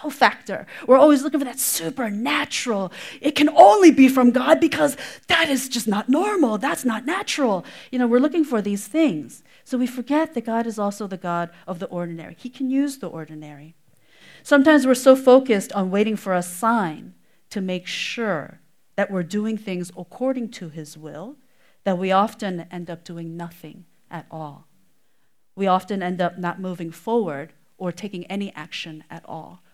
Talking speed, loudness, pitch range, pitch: 180 wpm, -20 LUFS, 175-260 Hz, 205 Hz